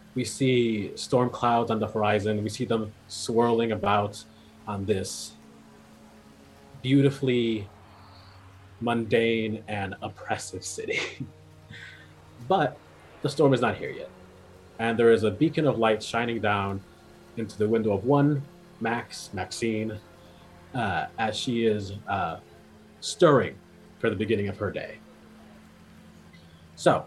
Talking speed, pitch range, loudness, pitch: 120 wpm, 95-115 Hz, -26 LUFS, 110 Hz